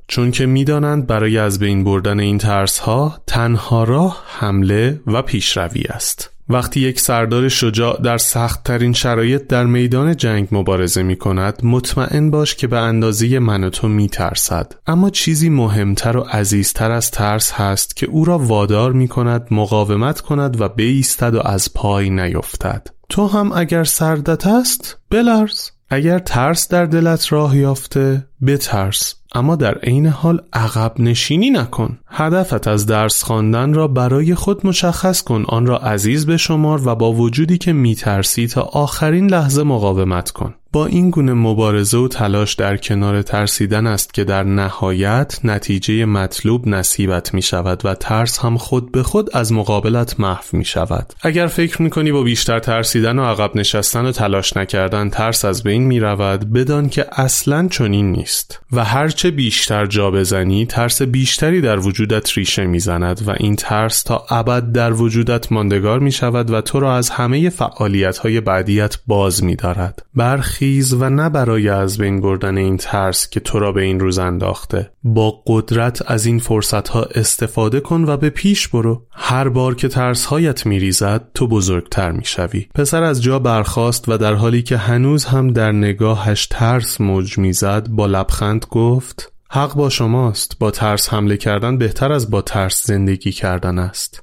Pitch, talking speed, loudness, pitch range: 115 Hz, 165 wpm, -15 LUFS, 105-135 Hz